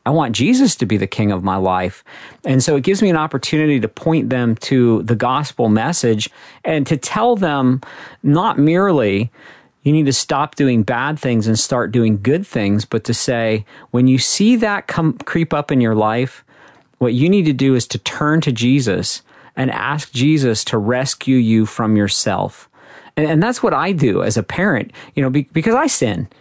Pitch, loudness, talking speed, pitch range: 130 Hz, -16 LUFS, 200 wpm, 115-155 Hz